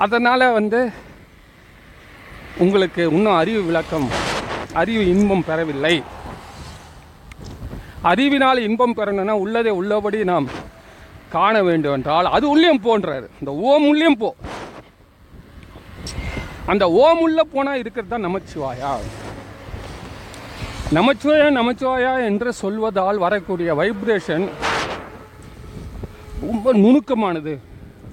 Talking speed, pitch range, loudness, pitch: 85 wpm, 145-245 Hz, -18 LUFS, 200 Hz